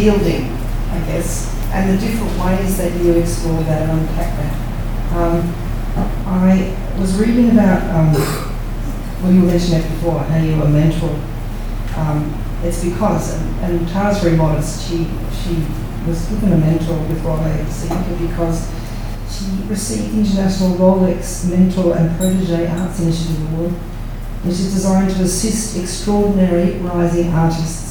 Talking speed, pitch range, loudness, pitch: 140 wpm, 150-185 Hz, -17 LUFS, 165 Hz